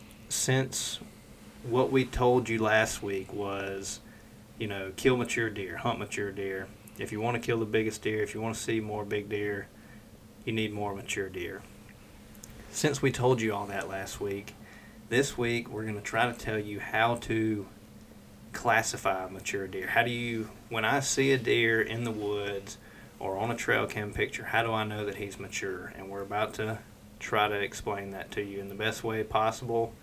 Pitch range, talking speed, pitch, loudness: 105-115 Hz, 195 wpm, 110 Hz, -31 LUFS